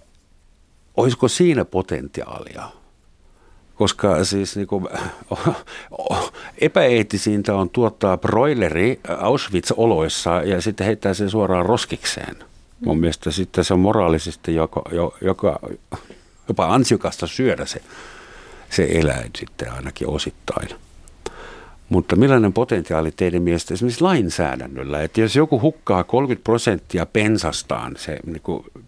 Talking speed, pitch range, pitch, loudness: 105 wpm, 85-110 Hz, 95 Hz, -20 LUFS